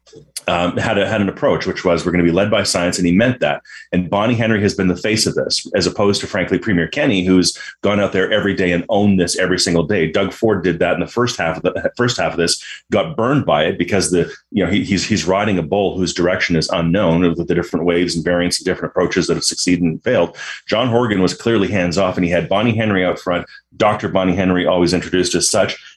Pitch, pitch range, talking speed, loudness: 90 Hz, 85-100 Hz, 260 wpm, -16 LUFS